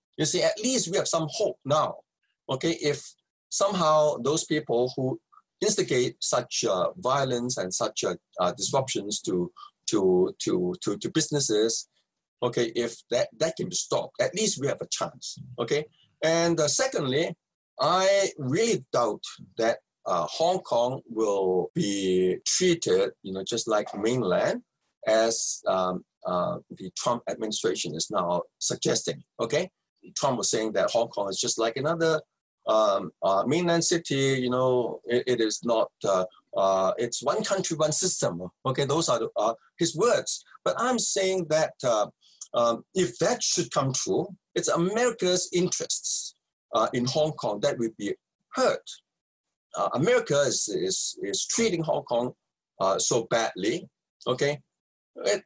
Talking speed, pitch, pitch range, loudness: 150 wpm, 155 Hz, 120-190 Hz, -26 LUFS